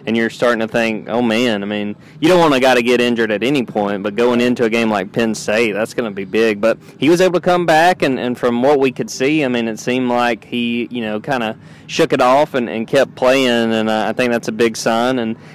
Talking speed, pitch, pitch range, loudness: 280 wpm, 120 Hz, 110-130 Hz, -16 LUFS